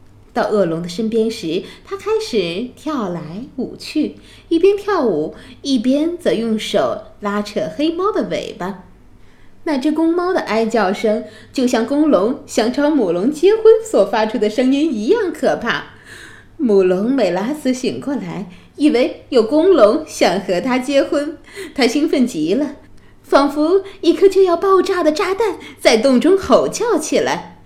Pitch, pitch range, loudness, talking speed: 280 Hz, 220-335 Hz, -16 LUFS, 215 characters per minute